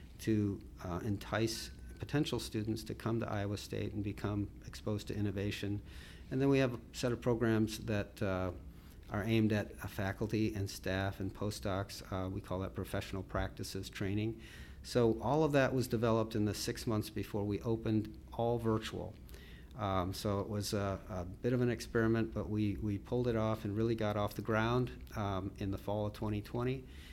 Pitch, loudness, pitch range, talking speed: 105 Hz, -37 LUFS, 100-115 Hz, 185 wpm